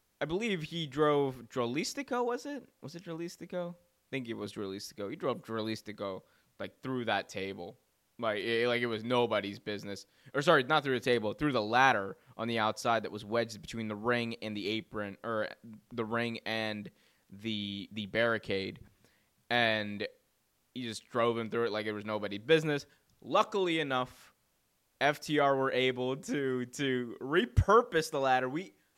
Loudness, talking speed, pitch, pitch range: -33 LUFS, 165 wpm, 120 Hz, 110-140 Hz